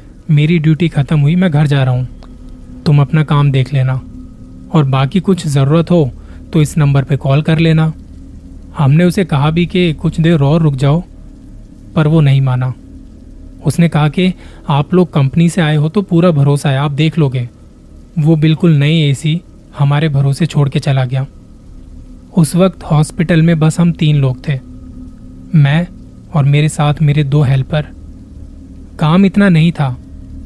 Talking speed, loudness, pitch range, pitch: 170 wpm, -12 LUFS, 135-165 Hz, 150 Hz